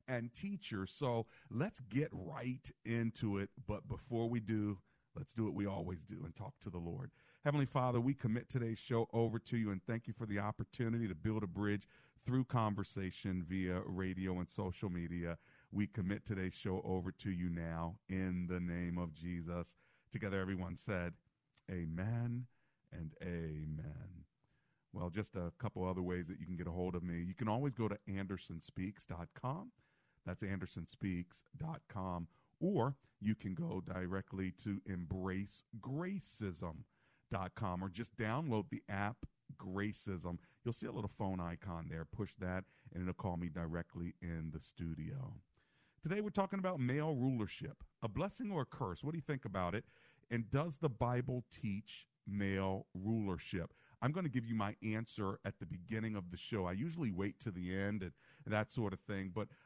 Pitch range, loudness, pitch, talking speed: 90-120 Hz, -42 LUFS, 105 Hz, 170 wpm